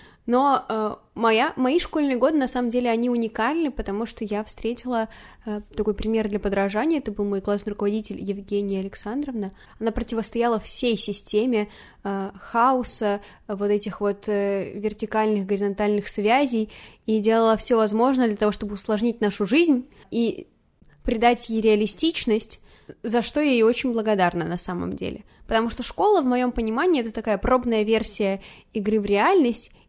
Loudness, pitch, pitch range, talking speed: -23 LUFS, 220 Hz, 210-240 Hz, 155 wpm